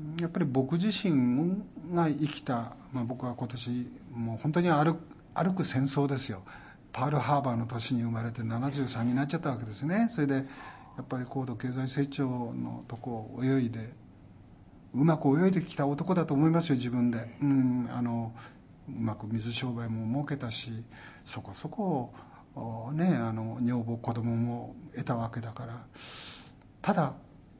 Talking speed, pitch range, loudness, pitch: 285 characters per minute, 115-145 Hz, -31 LUFS, 125 Hz